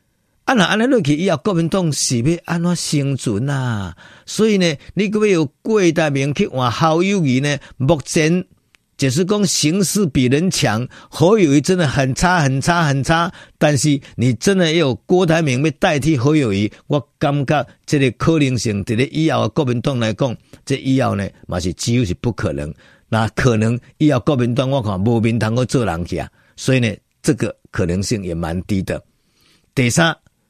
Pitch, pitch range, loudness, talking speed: 140 Hz, 120-165 Hz, -17 LUFS, 260 characters per minute